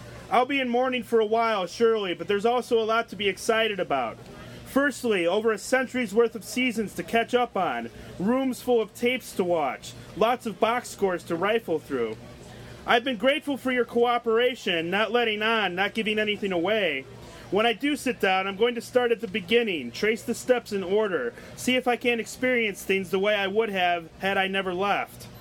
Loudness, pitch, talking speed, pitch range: -25 LUFS, 225 Hz, 205 wpm, 195-245 Hz